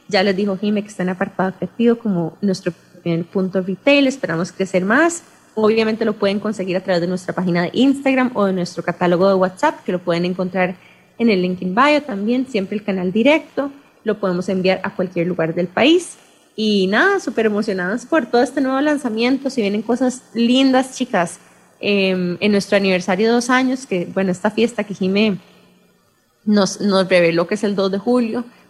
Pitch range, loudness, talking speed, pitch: 185-240 Hz, -18 LUFS, 190 wpm, 200 Hz